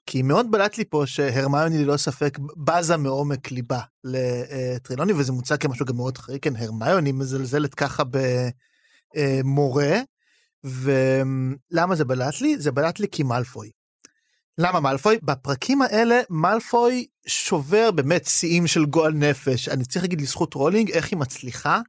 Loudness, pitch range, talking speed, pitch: -22 LUFS, 135-175 Hz, 140 wpm, 145 Hz